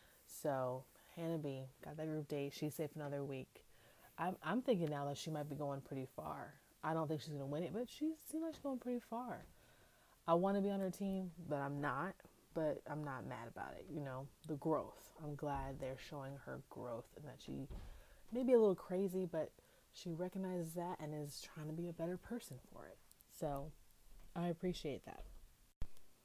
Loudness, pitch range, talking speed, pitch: -44 LUFS, 145-185 Hz, 205 wpm, 155 Hz